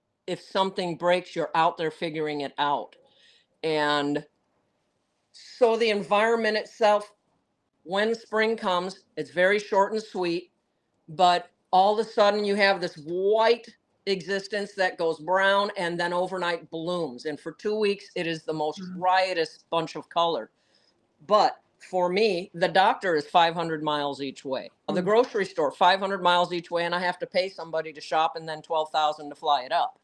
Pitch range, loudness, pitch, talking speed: 160-200 Hz, -26 LUFS, 180 Hz, 165 wpm